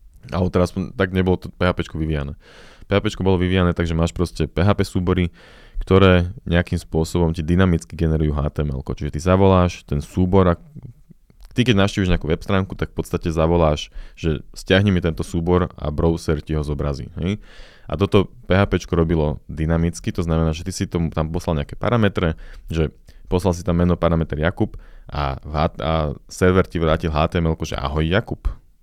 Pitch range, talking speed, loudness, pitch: 80-95 Hz, 170 wpm, -20 LUFS, 85 Hz